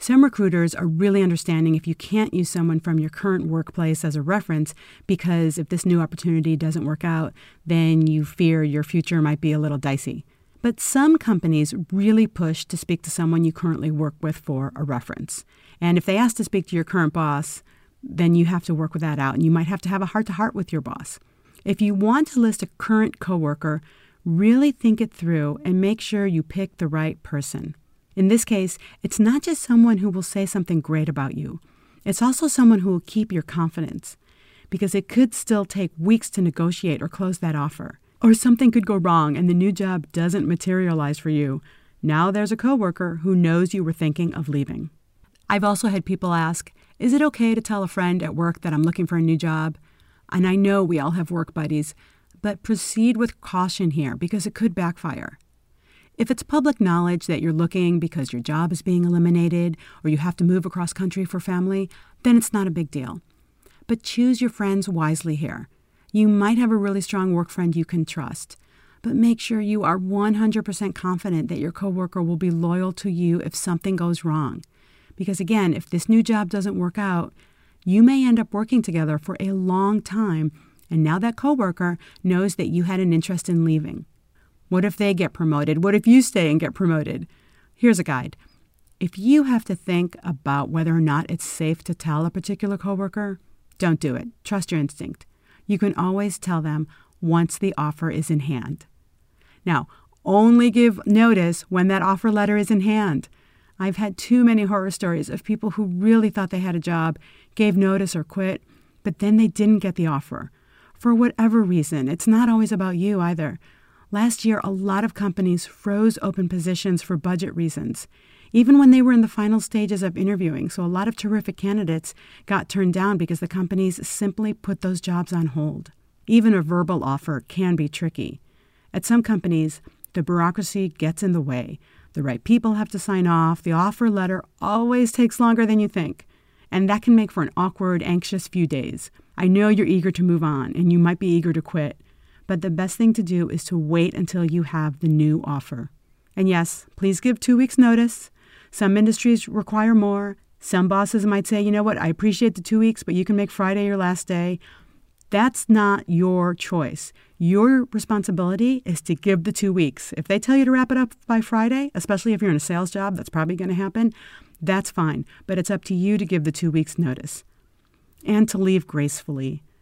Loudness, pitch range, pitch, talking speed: -21 LUFS, 165-210 Hz, 185 Hz, 205 wpm